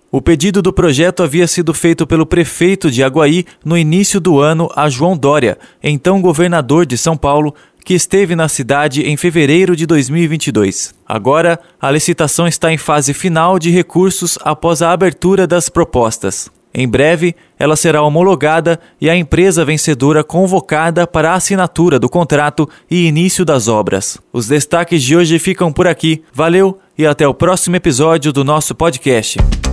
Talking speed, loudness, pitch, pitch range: 160 wpm, -11 LUFS, 165 Hz, 150-175 Hz